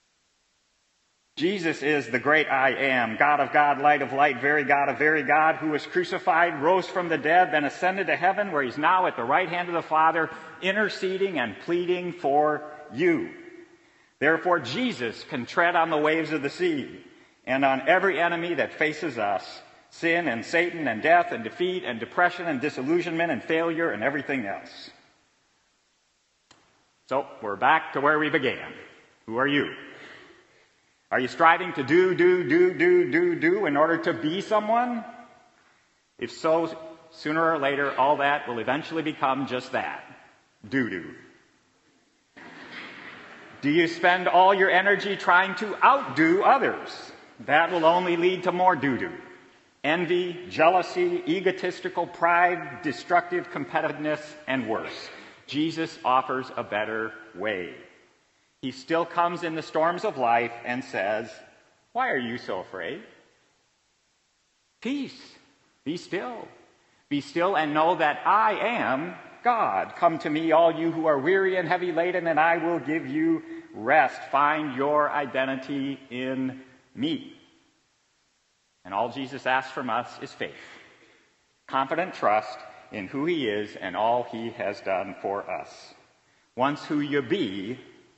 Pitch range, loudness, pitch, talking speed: 145-185 Hz, -25 LUFS, 165 Hz, 150 wpm